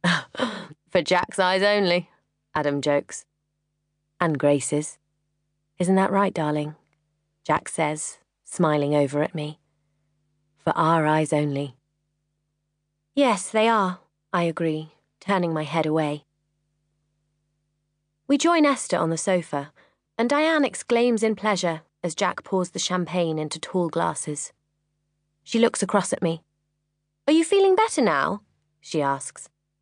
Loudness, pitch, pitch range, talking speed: -23 LUFS, 155 Hz, 150-185 Hz, 125 wpm